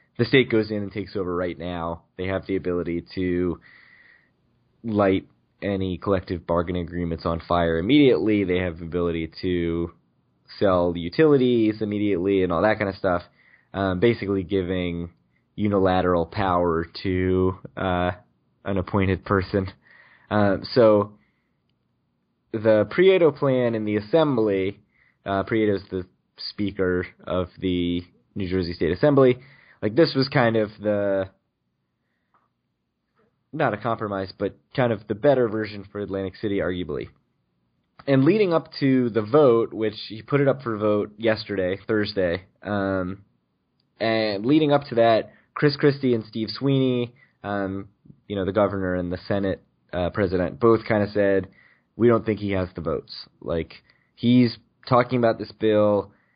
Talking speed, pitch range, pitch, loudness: 145 wpm, 90-115 Hz, 100 Hz, -23 LUFS